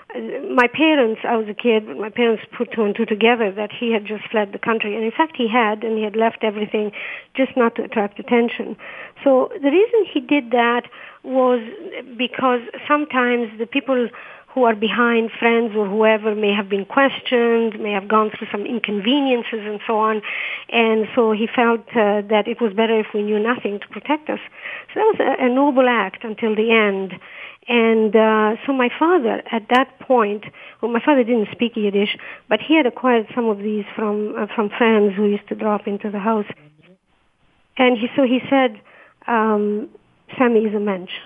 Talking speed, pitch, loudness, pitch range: 195 wpm, 225 Hz, -19 LUFS, 215-245 Hz